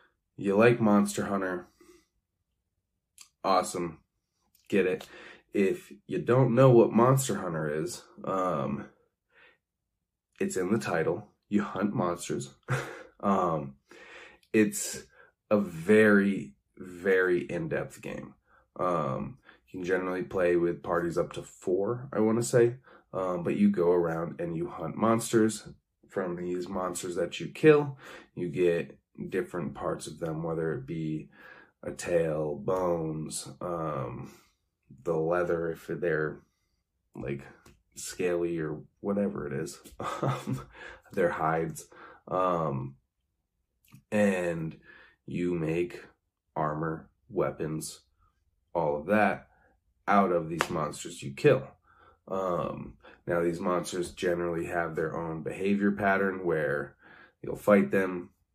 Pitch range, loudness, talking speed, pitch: 80-105 Hz, -29 LUFS, 115 wpm, 90 Hz